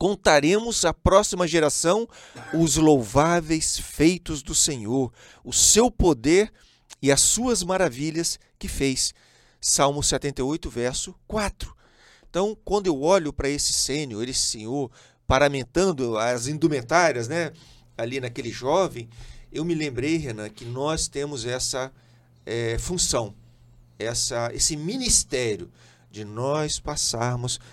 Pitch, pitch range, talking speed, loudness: 145 Hz, 125-165 Hz, 115 wpm, -23 LUFS